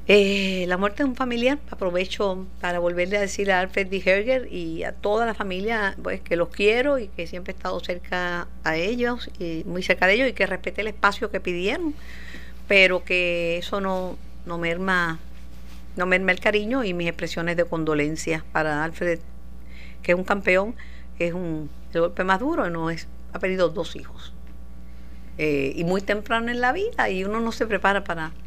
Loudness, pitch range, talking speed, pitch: -24 LUFS, 170-205 Hz, 190 wpm, 185 Hz